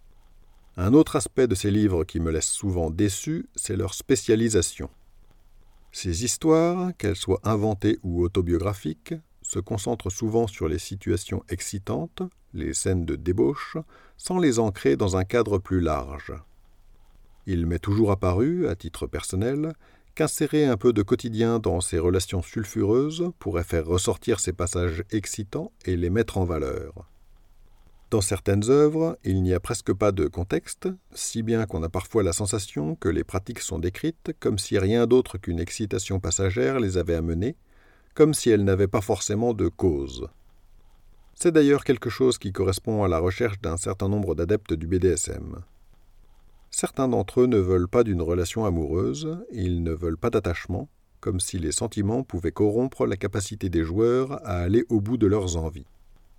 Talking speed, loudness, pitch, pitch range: 165 wpm, -25 LUFS, 100 Hz, 90-120 Hz